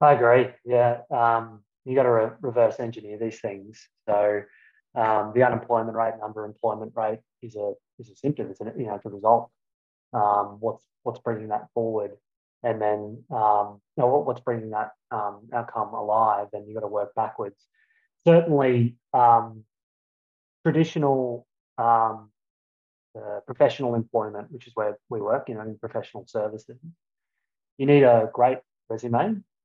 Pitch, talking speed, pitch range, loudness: 115 Hz, 155 wpm, 105-120 Hz, -24 LUFS